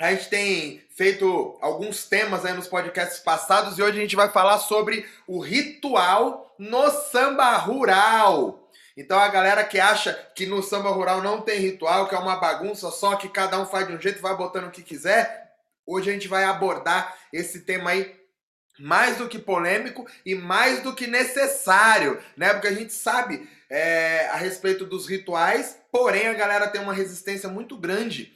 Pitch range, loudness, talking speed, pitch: 185-215 Hz, -22 LUFS, 185 wpm, 195 Hz